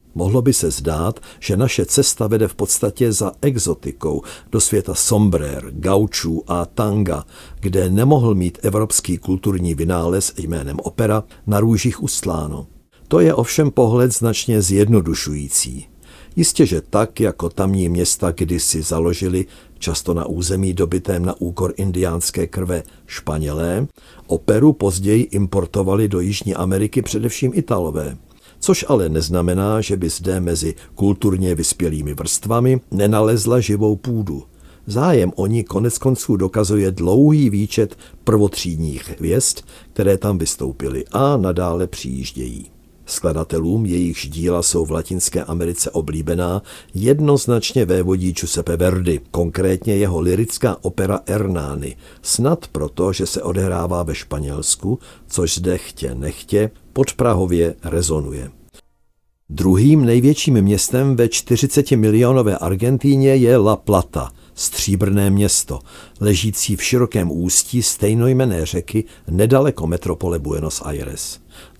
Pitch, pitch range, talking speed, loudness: 95 Hz, 85-110 Hz, 120 wpm, -18 LUFS